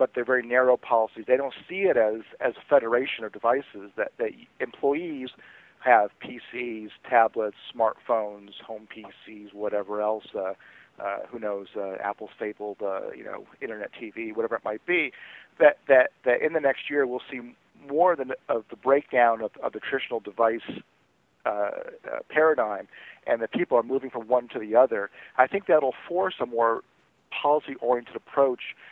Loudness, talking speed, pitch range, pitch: -26 LUFS, 170 wpm, 110-145 Hz, 125 Hz